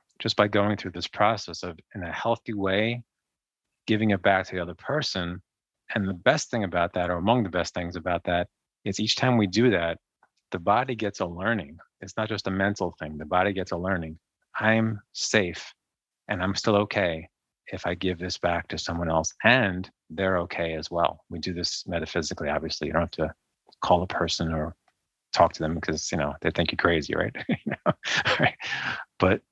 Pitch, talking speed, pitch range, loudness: 90 Hz, 205 wpm, 85-105 Hz, -26 LUFS